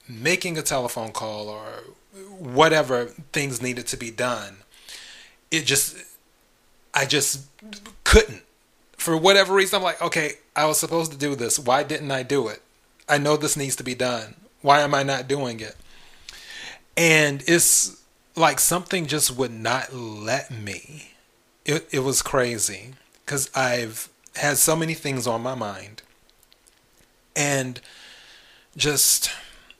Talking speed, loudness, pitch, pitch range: 140 wpm, -22 LUFS, 140 Hz, 125-160 Hz